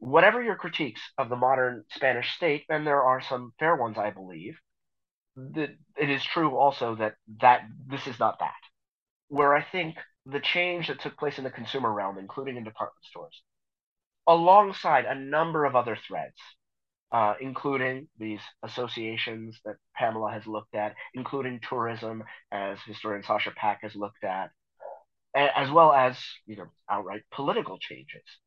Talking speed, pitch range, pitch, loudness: 160 wpm, 110-140 Hz, 125 Hz, -27 LUFS